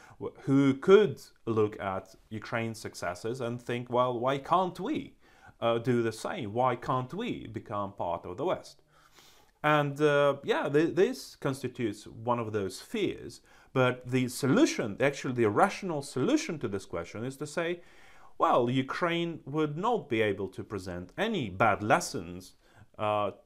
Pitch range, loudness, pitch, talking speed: 110-150 Hz, -30 LUFS, 125 Hz, 150 wpm